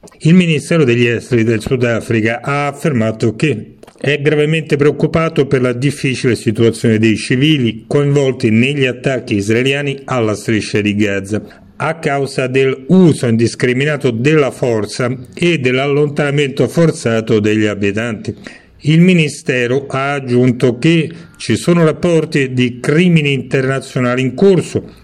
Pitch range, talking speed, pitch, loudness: 115-150 Hz, 120 wpm, 135 Hz, -14 LUFS